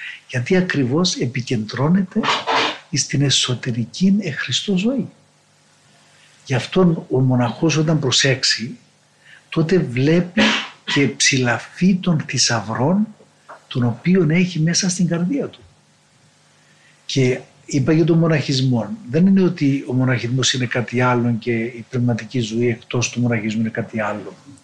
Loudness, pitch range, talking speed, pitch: -18 LUFS, 120-170 Hz, 120 wpm, 135 Hz